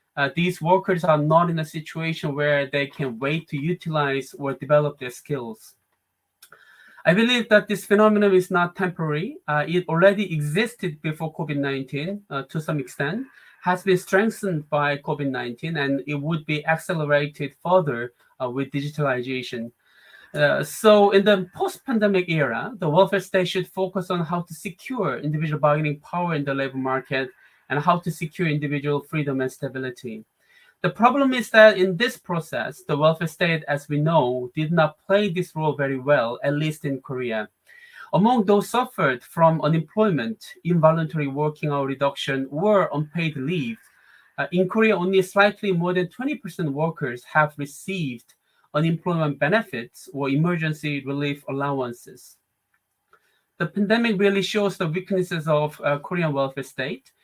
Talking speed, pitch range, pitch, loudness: 150 wpm, 145-190 Hz, 160 Hz, -23 LUFS